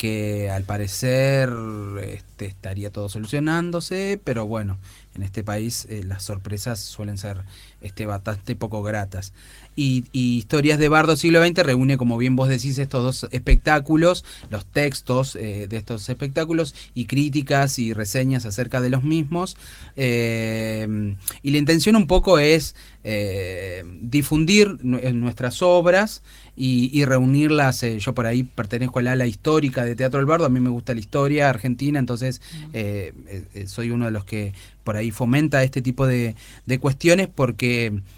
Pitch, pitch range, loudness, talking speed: 125 Hz, 105-140 Hz, -21 LUFS, 160 wpm